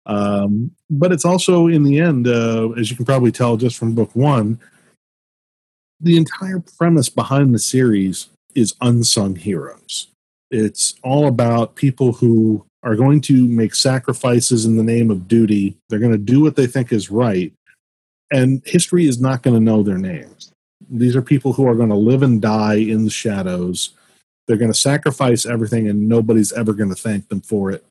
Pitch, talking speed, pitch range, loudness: 120 Hz, 185 wpm, 110-135 Hz, -16 LUFS